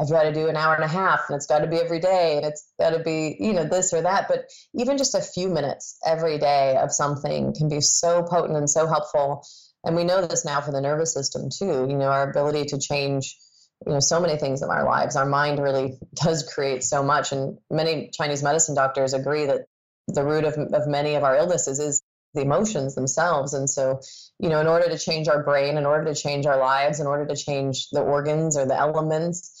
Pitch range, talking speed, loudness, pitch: 140-160 Hz, 240 wpm, -23 LUFS, 150 Hz